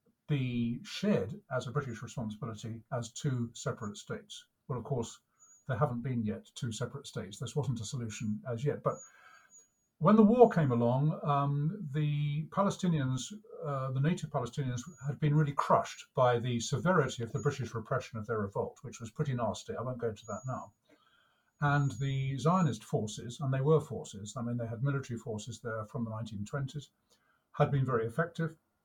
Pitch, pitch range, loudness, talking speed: 135 Hz, 120-150 Hz, -33 LUFS, 175 wpm